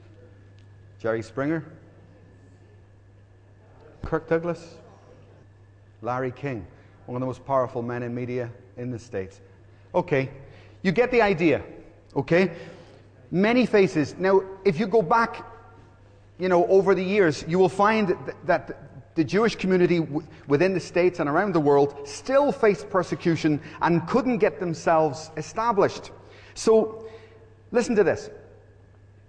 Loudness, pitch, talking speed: -24 LUFS, 140 Hz, 130 wpm